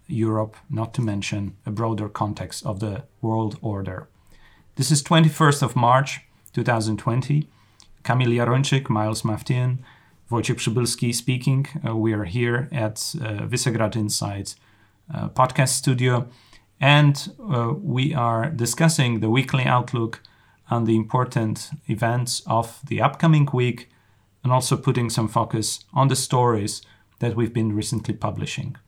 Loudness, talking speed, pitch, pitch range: -22 LUFS, 135 wpm, 120 Hz, 110-130 Hz